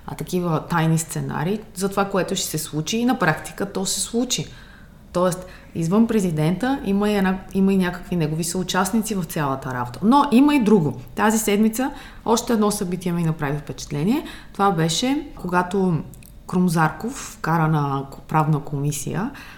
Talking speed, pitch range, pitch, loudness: 155 wpm, 155-210 Hz, 185 Hz, -21 LUFS